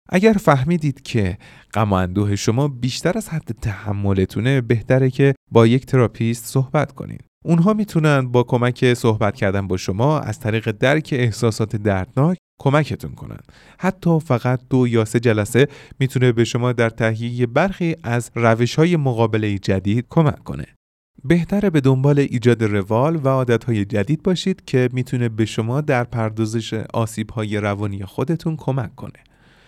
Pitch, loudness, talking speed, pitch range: 125 Hz, -19 LUFS, 145 wpm, 110-145 Hz